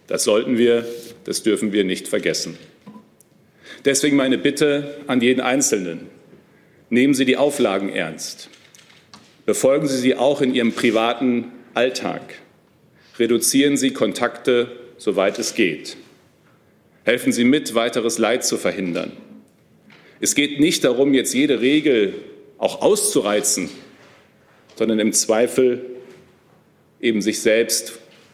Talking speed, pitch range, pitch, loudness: 115 wpm, 120-150 Hz, 130 Hz, -19 LUFS